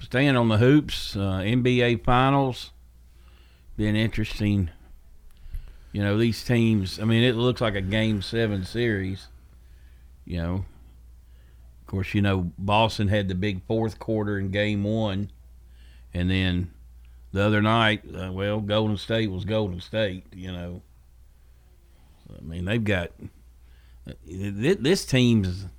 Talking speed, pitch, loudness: 135 wpm, 95 Hz, -24 LUFS